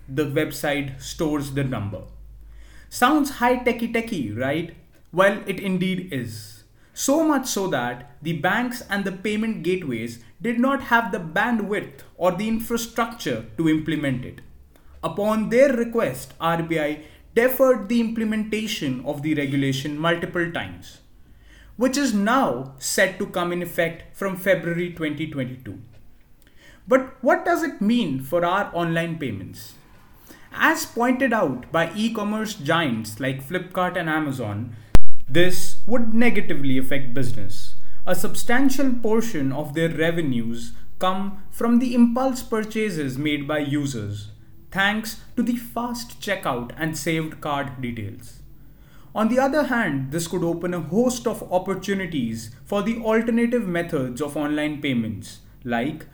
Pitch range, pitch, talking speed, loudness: 140-225 Hz, 170 Hz, 135 wpm, -23 LUFS